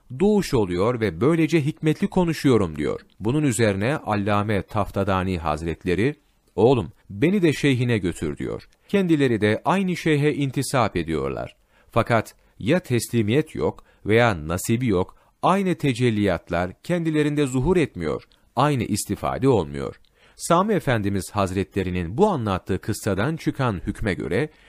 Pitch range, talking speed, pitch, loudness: 100-155 Hz, 115 wpm, 120 Hz, -23 LUFS